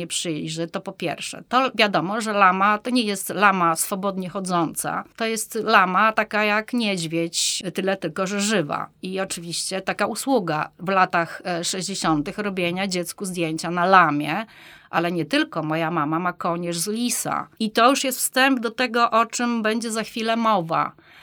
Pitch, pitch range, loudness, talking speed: 195 Hz, 170-220 Hz, -22 LUFS, 170 wpm